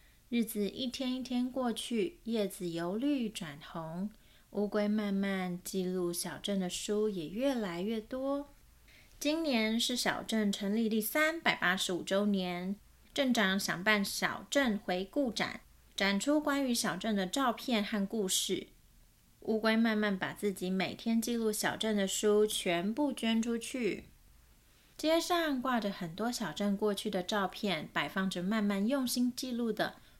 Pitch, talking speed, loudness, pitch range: 215 Hz, 215 characters per minute, -33 LUFS, 190-240 Hz